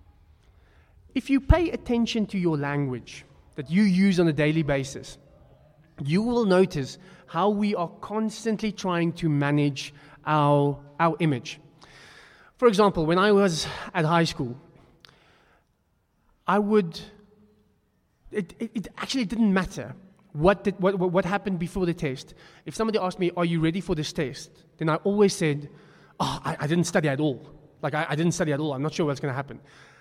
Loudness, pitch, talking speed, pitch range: -25 LUFS, 165 Hz, 170 wpm, 150-195 Hz